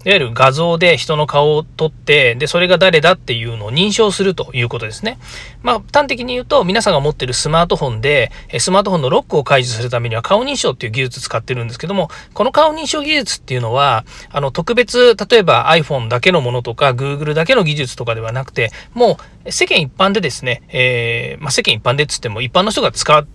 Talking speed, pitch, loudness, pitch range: 470 characters per minute, 150 Hz, -14 LUFS, 125-185 Hz